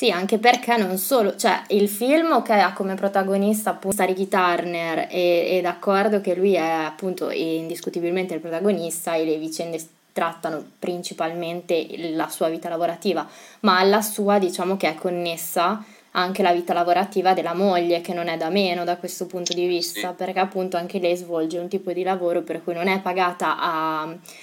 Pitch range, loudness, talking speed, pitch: 170-195 Hz, -22 LUFS, 175 wpm, 180 Hz